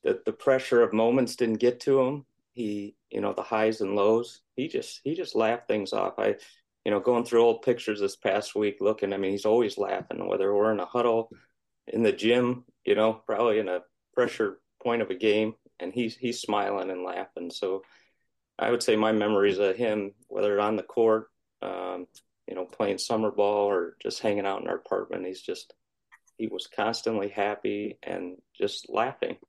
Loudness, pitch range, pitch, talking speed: -28 LUFS, 100-120 Hz, 110 Hz, 195 wpm